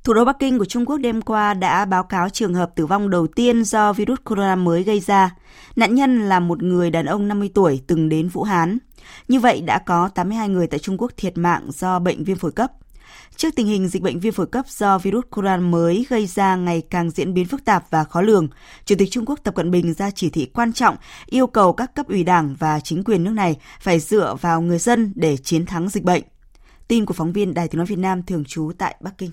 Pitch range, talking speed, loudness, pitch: 175-220 Hz, 250 wpm, -19 LUFS, 190 Hz